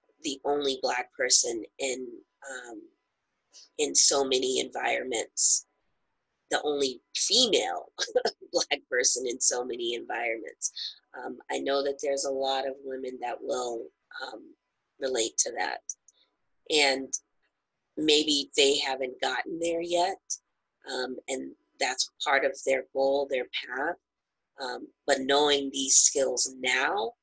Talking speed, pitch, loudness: 125 wpm, 145 Hz, -27 LUFS